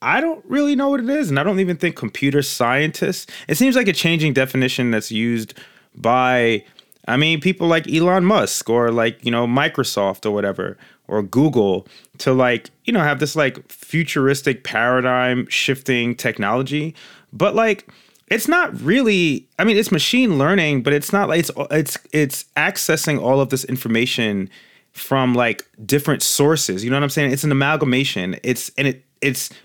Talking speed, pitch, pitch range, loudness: 175 wpm, 140 Hz, 125-170 Hz, -18 LUFS